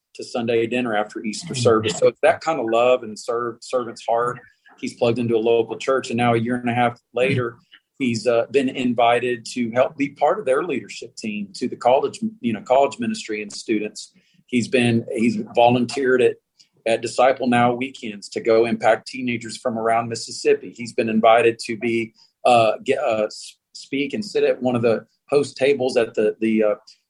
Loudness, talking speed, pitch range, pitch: -21 LUFS, 195 wpm, 115-140 Hz, 120 Hz